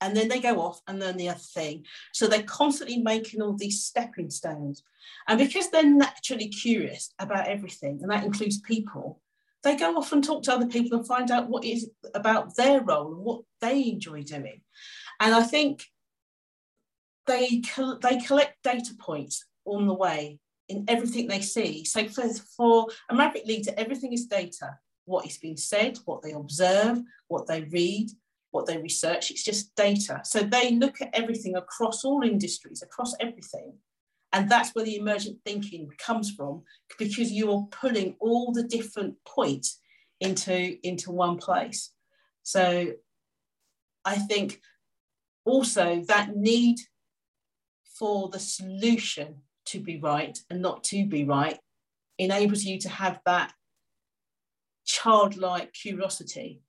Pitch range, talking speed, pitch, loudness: 185-235 Hz, 150 wpm, 210 Hz, -27 LUFS